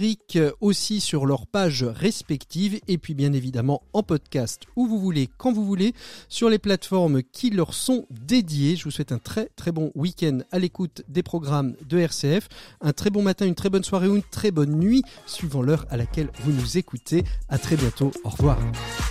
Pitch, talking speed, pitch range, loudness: 165 Hz, 200 wpm, 140-200 Hz, -24 LUFS